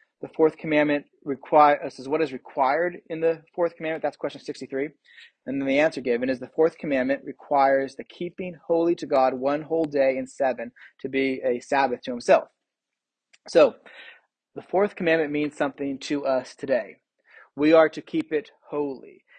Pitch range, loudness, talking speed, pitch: 135-165 Hz, -24 LUFS, 175 wpm, 150 Hz